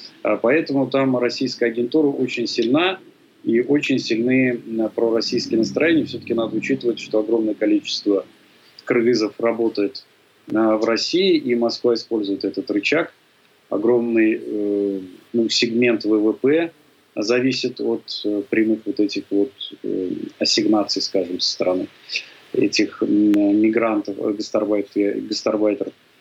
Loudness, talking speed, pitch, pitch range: -20 LUFS, 100 wpm, 115 Hz, 105-130 Hz